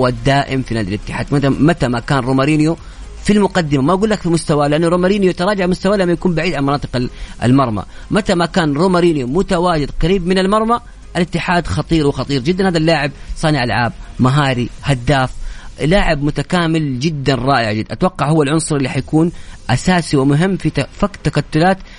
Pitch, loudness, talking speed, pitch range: 150 Hz, -15 LUFS, 160 wpm, 135-180 Hz